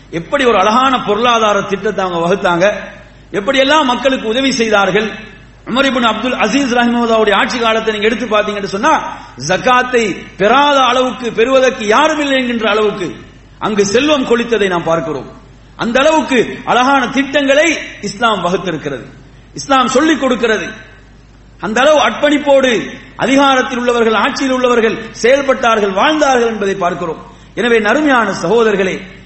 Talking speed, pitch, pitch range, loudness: 105 wpm, 230 Hz, 200-260 Hz, -12 LUFS